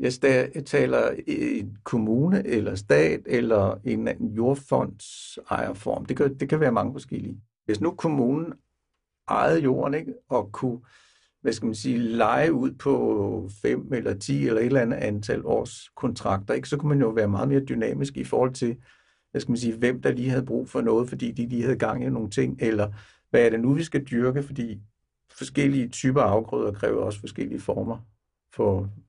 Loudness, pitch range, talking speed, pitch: -25 LUFS, 110-135 Hz, 190 wpm, 120 Hz